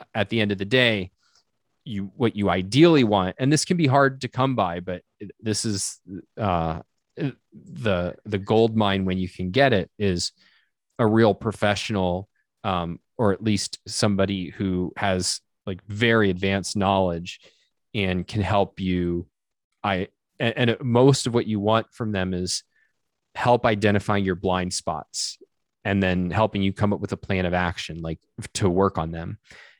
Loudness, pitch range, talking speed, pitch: -23 LUFS, 90-115 Hz, 165 wpm, 100 Hz